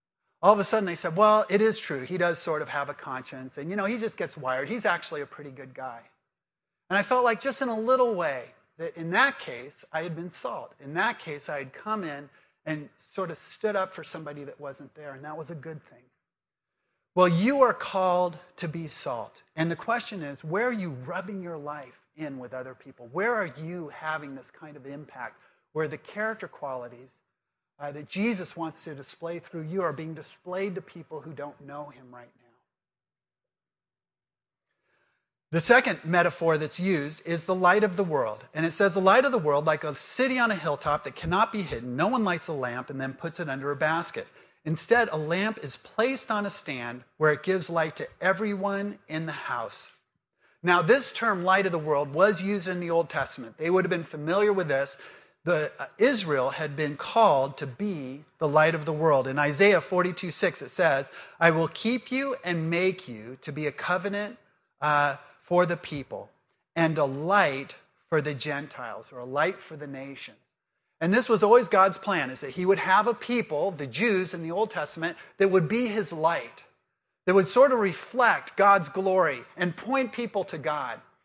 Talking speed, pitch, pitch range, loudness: 210 wpm, 170 Hz, 150-200 Hz, -26 LUFS